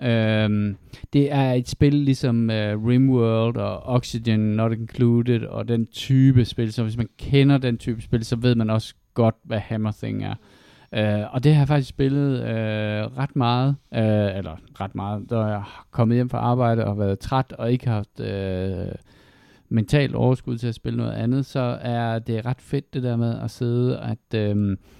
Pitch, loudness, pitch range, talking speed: 115 Hz, -22 LUFS, 110-125 Hz, 190 wpm